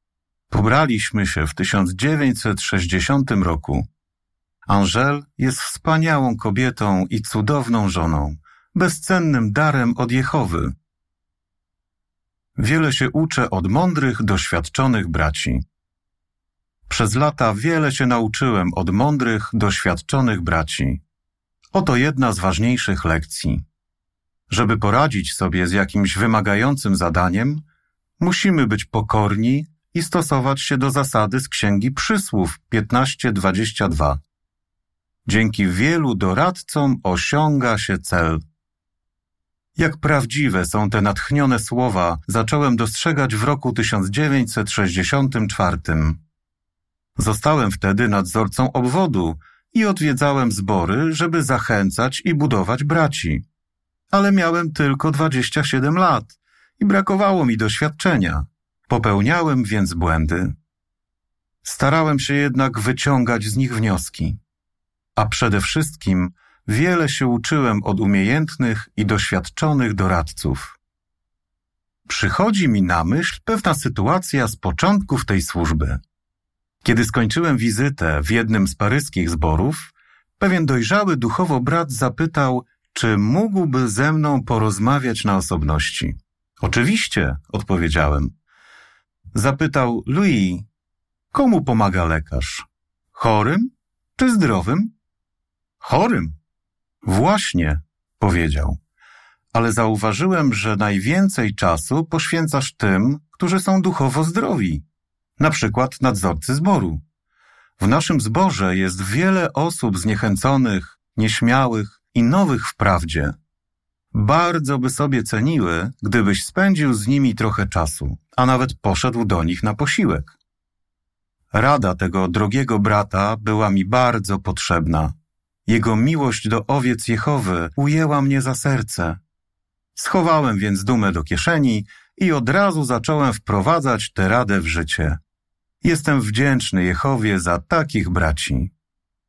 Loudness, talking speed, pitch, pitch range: -19 LUFS, 105 wpm, 110 Hz, 90-140 Hz